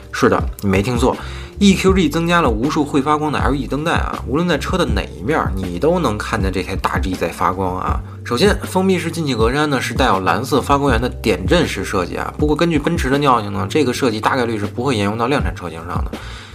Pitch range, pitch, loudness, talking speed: 100-150 Hz, 135 Hz, -17 LUFS, 360 characters per minute